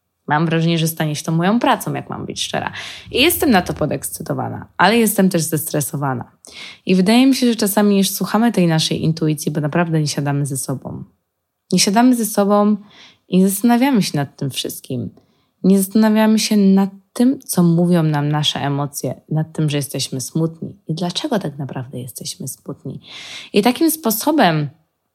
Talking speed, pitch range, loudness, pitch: 175 wpm, 150-210 Hz, -17 LUFS, 175 Hz